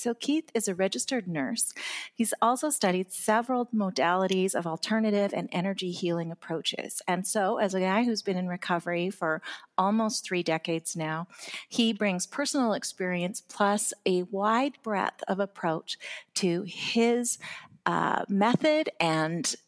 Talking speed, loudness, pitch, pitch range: 140 wpm, -28 LUFS, 195 Hz, 175-225 Hz